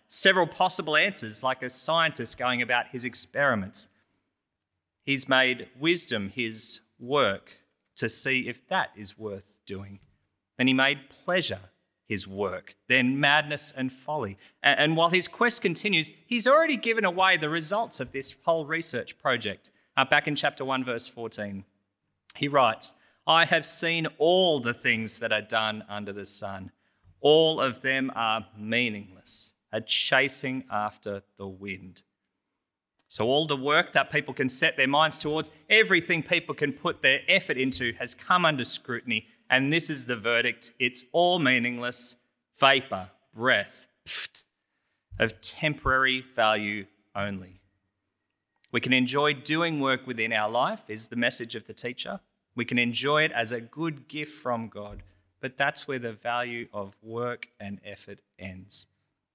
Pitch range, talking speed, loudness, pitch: 105-150 Hz, 150 wpm, -25 LUFS, 125 Hz